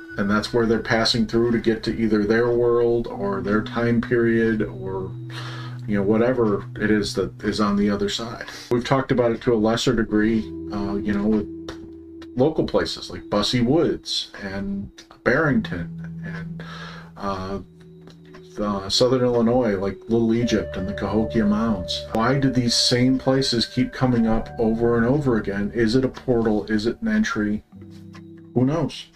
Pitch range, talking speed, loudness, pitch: 105-125 Hz, 165 wpm, -22 LUFS, 115 Hz